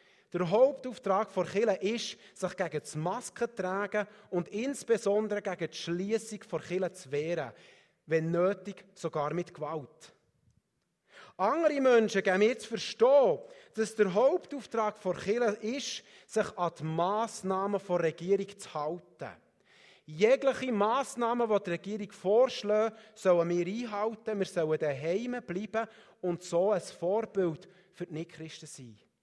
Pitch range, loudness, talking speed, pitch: 175-220 Hz, -31 LUFS, 135 wpm, 195 Hz